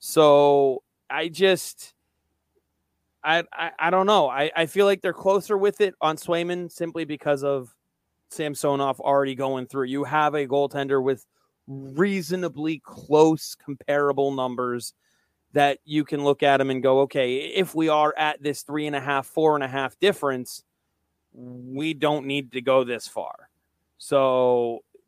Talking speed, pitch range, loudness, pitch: 155 wpm, 135-160 Hz, -23 LUFS, 145 Hz